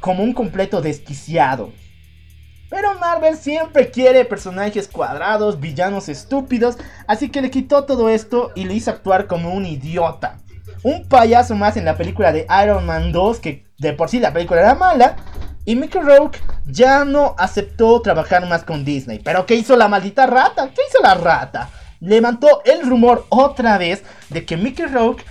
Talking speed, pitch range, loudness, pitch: 170 wpm, 165-255 Hz, -15 LUFS, 210 Hz